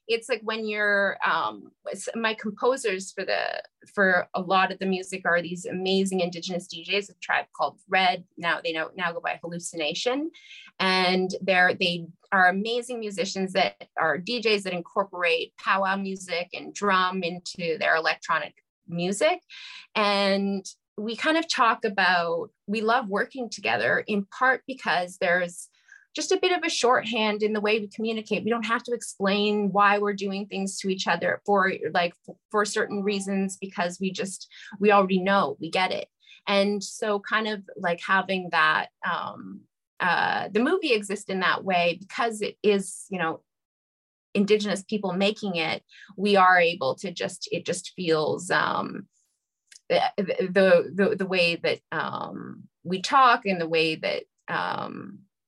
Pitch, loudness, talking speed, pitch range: 195 Hz, -25 LUFS, 160 wpm, 180-215 Hz